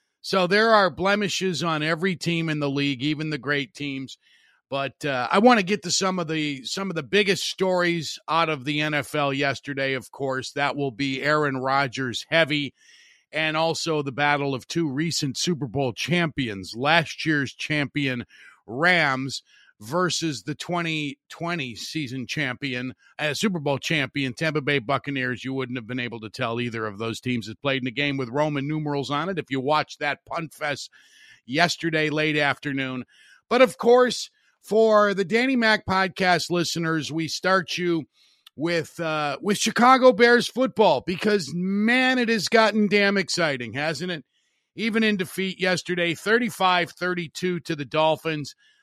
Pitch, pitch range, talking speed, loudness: 155 Hz, 140-185 Hz, 165 wpm, -23 LUFS